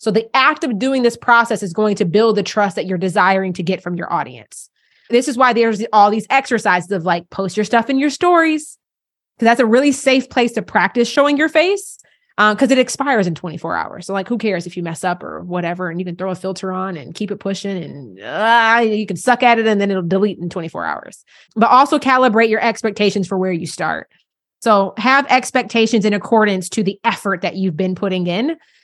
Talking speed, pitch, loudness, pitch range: 230 wpm, 215 Hz, -16 LUFS, 190-245 Hz